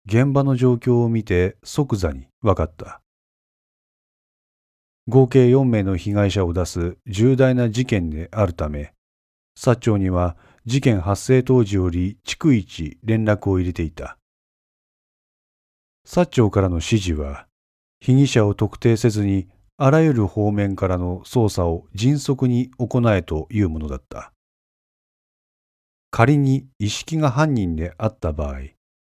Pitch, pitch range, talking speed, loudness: 100 Hz, 85-125 Hz, 230 characters per minute, -20 LUFS